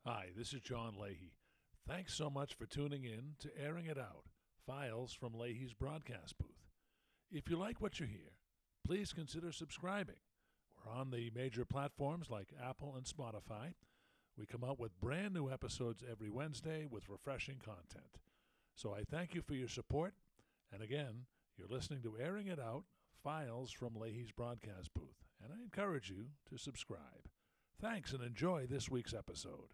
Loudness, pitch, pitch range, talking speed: -47 LUFS, 130 Hz, 115-150 Hz, 165 wpm